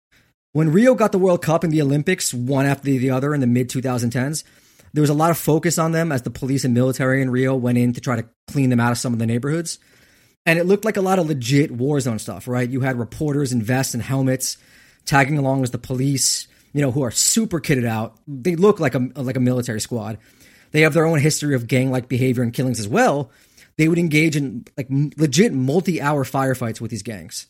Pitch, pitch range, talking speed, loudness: 135 Hz, 125-155 Hz, 240 wpm, -19 LUFS